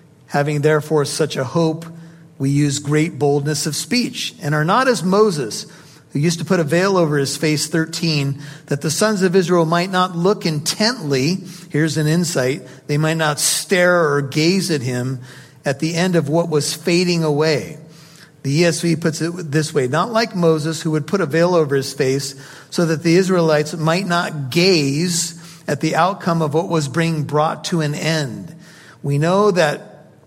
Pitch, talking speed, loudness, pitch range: 160 Hz, 180 wpm, -18 LUFS, 150-175 Hz